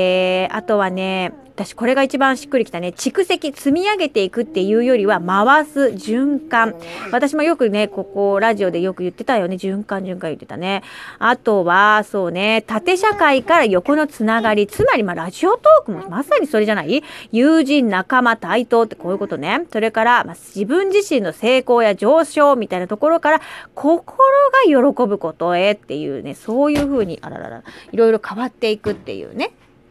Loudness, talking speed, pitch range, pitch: -17 LUFS, 360 characters per minute, 195-280 Hz, 230 Hz